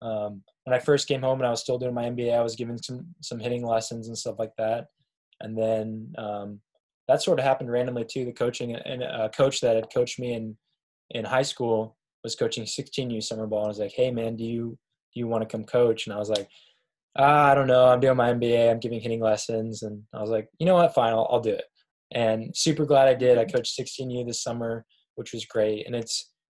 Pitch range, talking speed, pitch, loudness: 110-125 Hz, 245 wpm, 115 Hz, -25 LUFS